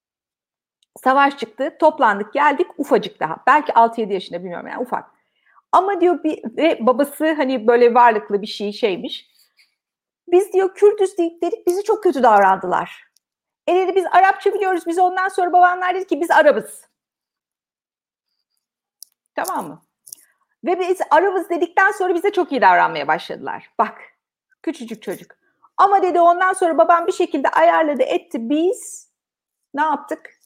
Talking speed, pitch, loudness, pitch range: 145 wpm, 340 Hz, -17 LUFS, 265-370 Hz